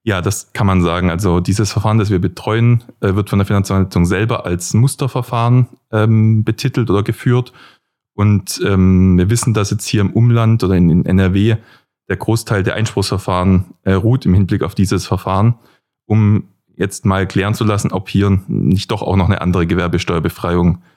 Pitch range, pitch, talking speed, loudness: 95-110 Hz, 100 Hz, 165 wpm, -15 LUFS